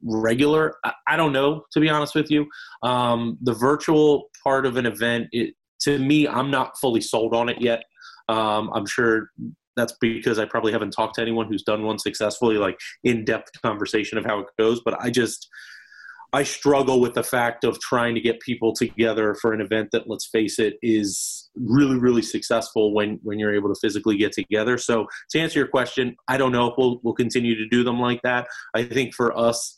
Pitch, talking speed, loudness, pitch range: 120 Hz, 205 wpm, -22 LUFS, 110-130 Hz